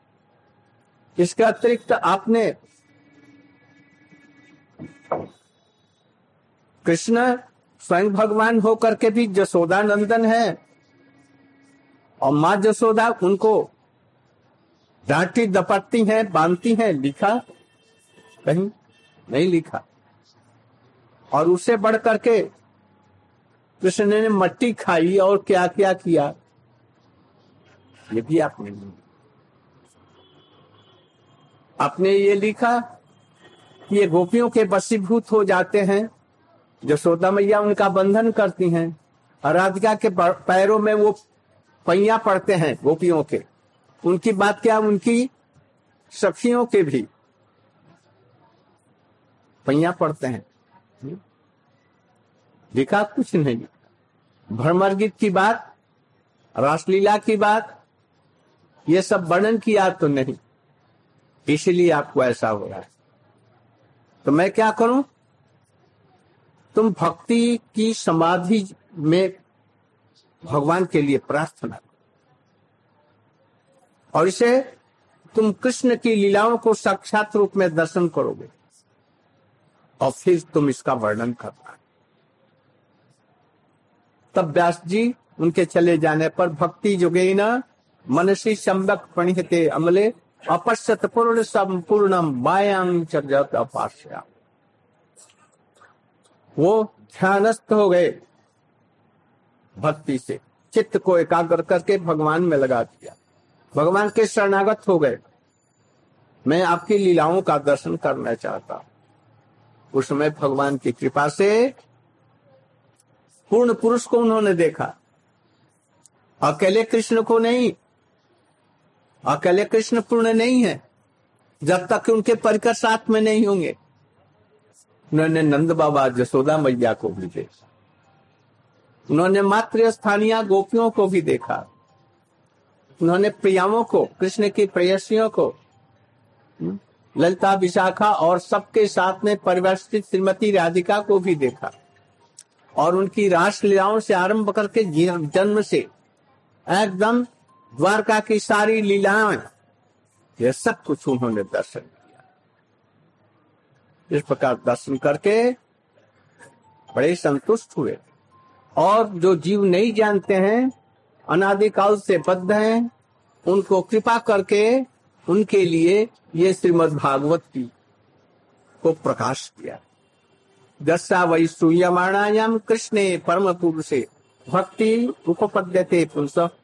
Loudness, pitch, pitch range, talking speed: -20 LUFS, 185 Hz, 150-215 Hz, 95 wpm